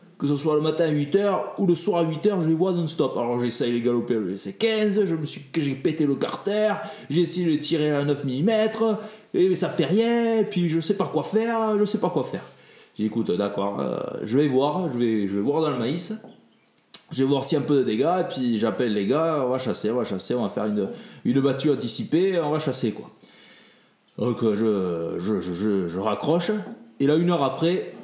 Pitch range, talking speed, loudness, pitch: 125-190 Hz, 235 wpm, -24 LUFS, 155 Hz